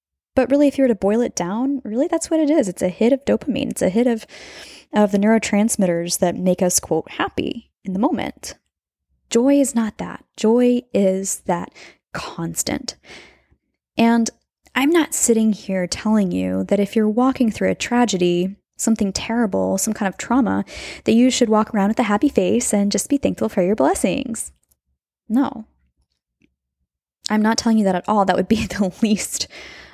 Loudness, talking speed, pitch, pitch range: -19 LUFS, 180 wpm, 215 Hz, 185-245 Hz